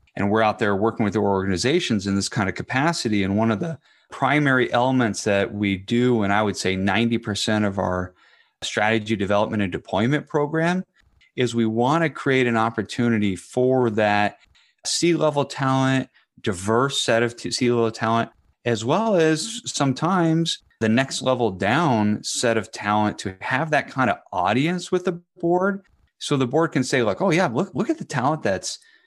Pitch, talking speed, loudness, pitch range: 120 Hz, 175 wpm, -22 LUFS, 105-145 Hz